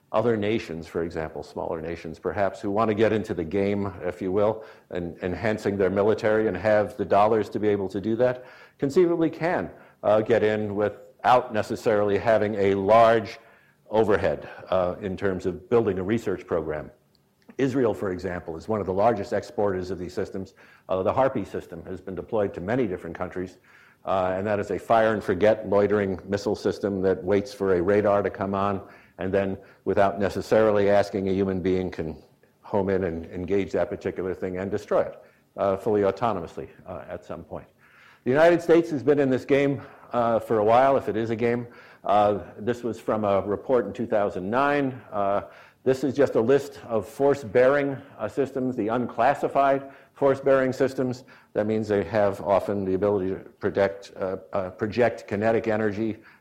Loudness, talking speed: -25 LUFS, 185 wpm